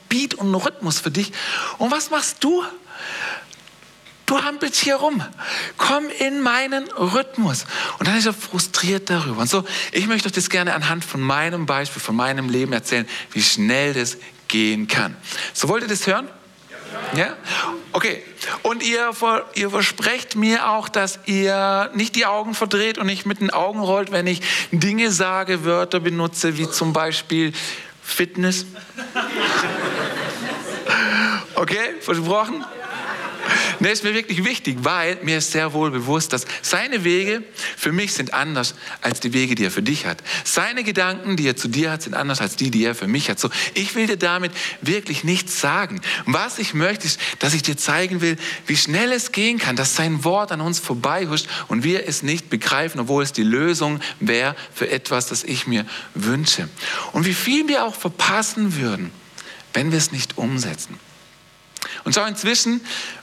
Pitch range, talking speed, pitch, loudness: 150-215 Hz, 175 wpm, 180 Hz, -20 LUFS